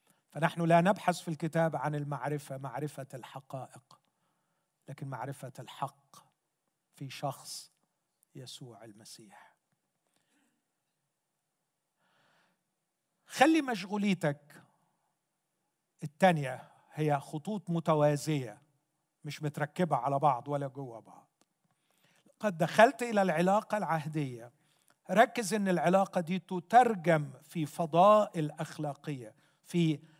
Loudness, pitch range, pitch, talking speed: -30 LUFS, 145-185 Hz, 160 Hz, 85 wpm